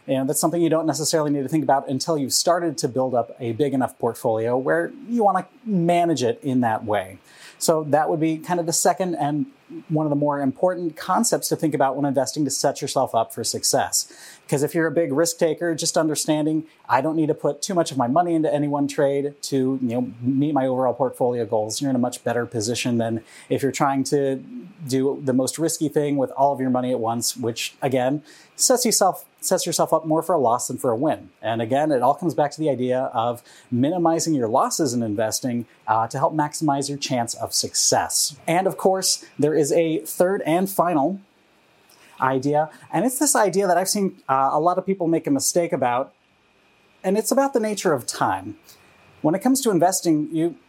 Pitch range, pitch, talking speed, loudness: 135-170 Hz, 150 Hz, 220 wpm, -22 LUFS